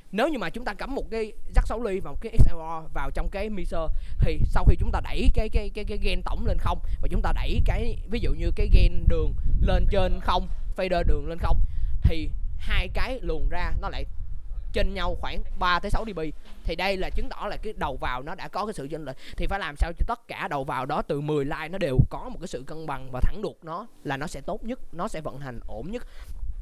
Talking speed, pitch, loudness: 265 wpm, 150 Hz, -29 LUFS